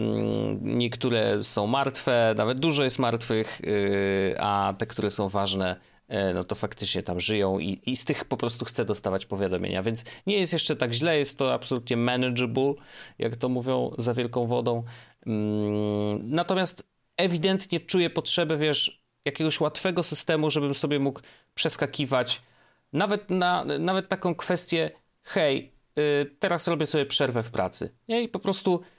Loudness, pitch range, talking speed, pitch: -26 LUFS, 110-160 Hz, 145 wpm, 130 Hz